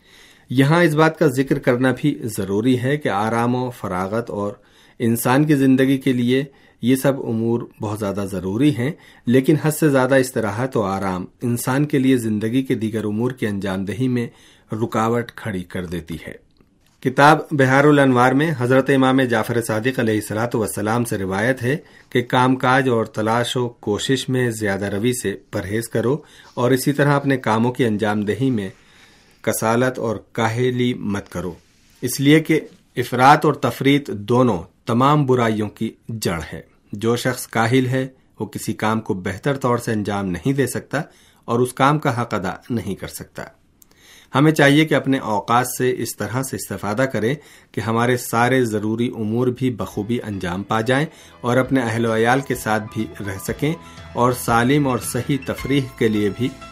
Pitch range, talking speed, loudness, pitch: 105-130 Hz, 175 wpm, -19 LUFS, 120 Hz